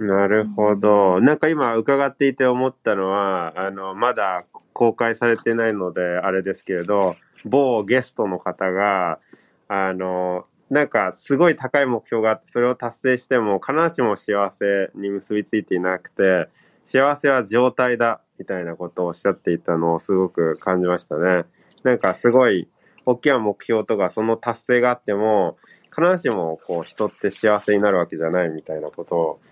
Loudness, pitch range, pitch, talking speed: -20 LUFS, 95-120 Hz, 105 Hz, 335 characters per minute